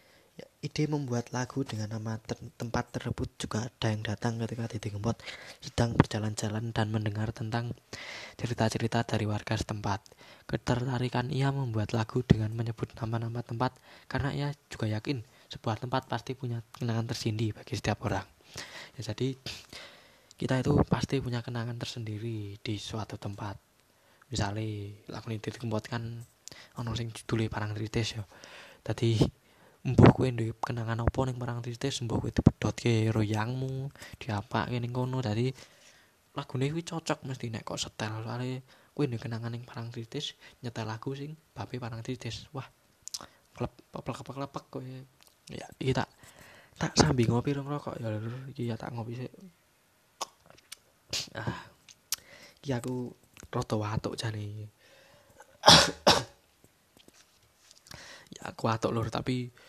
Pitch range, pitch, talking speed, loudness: 110-130 Hz, 115 Hz, 135 wpm, -32 LUFS